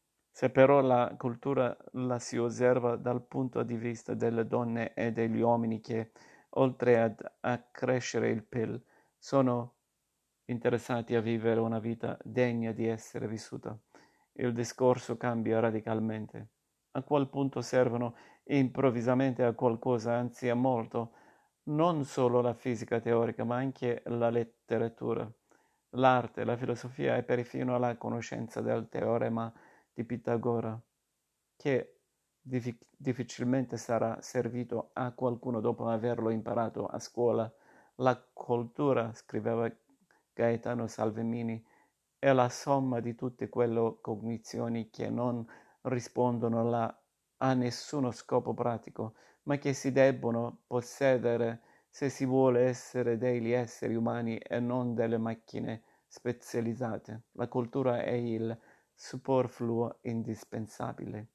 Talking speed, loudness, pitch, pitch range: 120 wpm, -32 LUFS, 120 Hz, 115-125 Hz